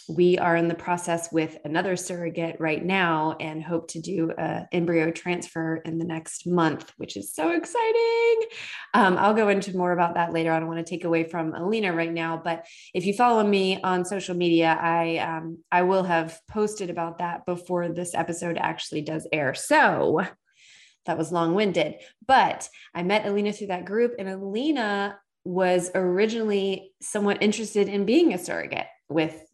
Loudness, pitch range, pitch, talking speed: -25 LUFS, 165-200 Hz, 175 Hz, 180 wpm